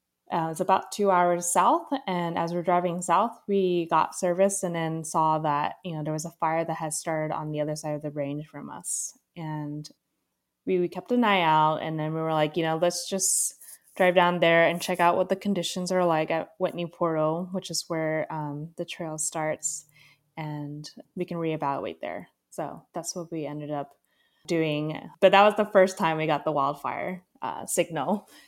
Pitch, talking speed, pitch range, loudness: 165 Hz, 205 wpm, 155-180 Hz, -26 LUFS